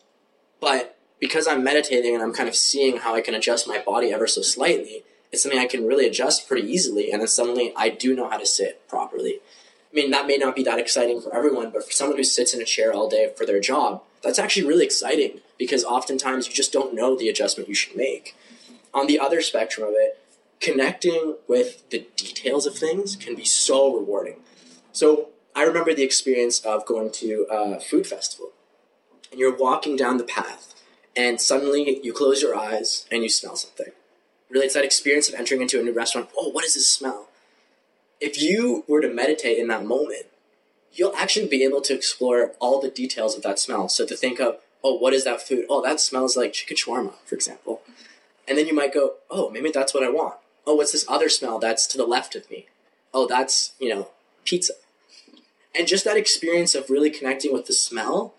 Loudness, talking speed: -22 LUFS, 210 wpm